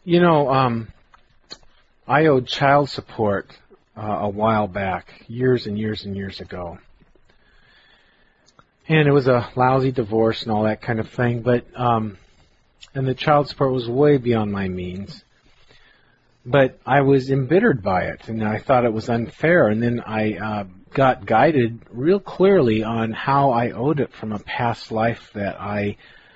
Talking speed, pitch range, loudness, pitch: 160 wpm, 105-135 Hz, -20 LUFS, 115 Hz